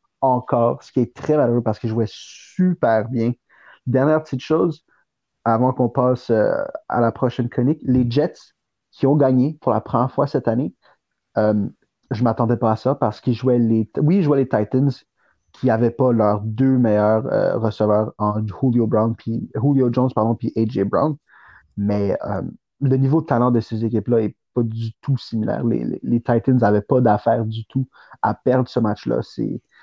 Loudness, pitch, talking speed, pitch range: -20 LUFS, 120 Hz, 195 wpm, 110-130 Hz